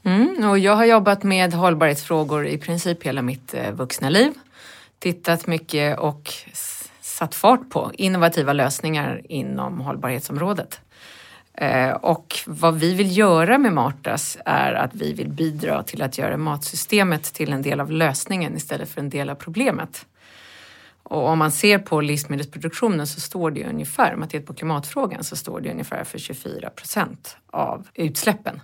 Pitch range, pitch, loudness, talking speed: 145-185 Hz, 160 Hz, -21 LUFS, 150 wpm